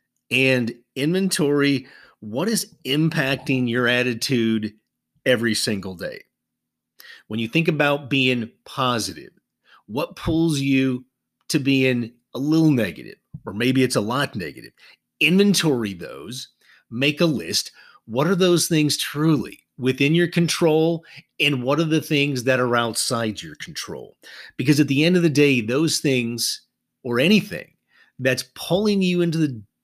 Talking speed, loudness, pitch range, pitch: 140 wpm, -21 LUFS, 120-155 Hz, 135 Hz